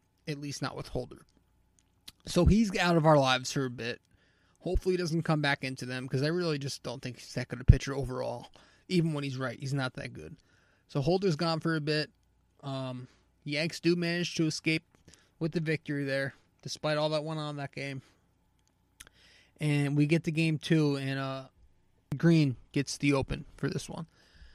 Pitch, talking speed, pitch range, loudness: 140 Hz, 195 wpm, 125-160 Hz, -31 LUFS